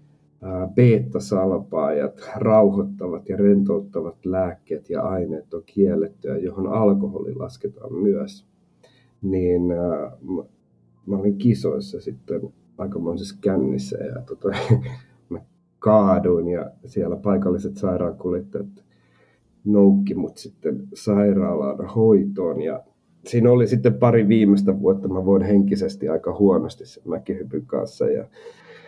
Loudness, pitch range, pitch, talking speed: -21 LUFS, 95-120 Hz, 100 Hz, 105 wpm